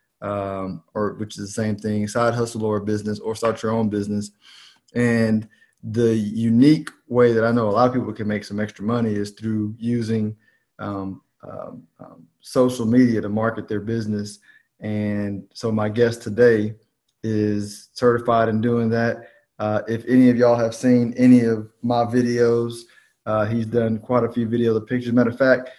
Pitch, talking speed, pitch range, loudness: 115 Hz, 180 wpm, 105-120 Hz, -21 LUFS